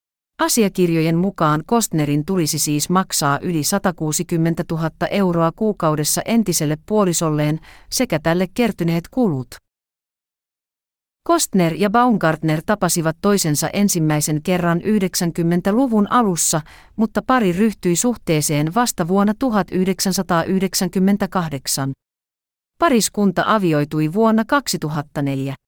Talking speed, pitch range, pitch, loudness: 85 wpm, 155-205 Hz, 175 Hz, -18 LUFS